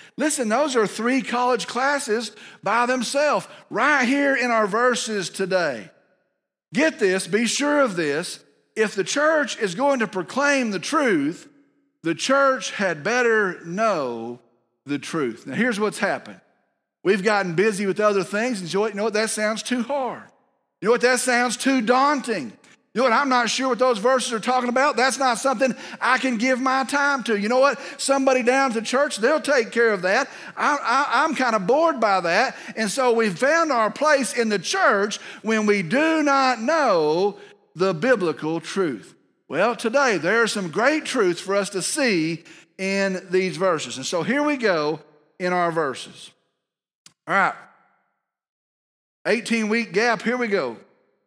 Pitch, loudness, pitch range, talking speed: 235 Hz, -21 LUFS, 200-270 Hz, 175 wpm